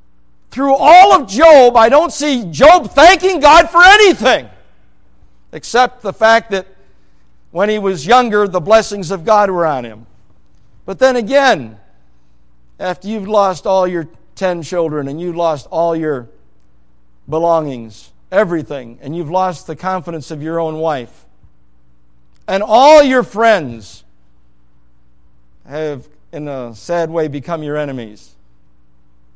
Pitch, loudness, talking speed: 160 Hz, -12 LUFS, 135 wpm